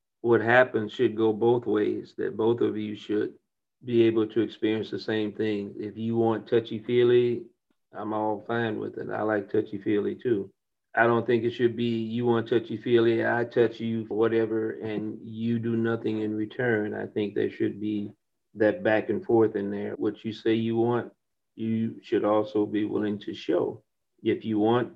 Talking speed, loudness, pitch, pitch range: 190 wpm, -27 LUFS, 110 Hz, 105-115 Hz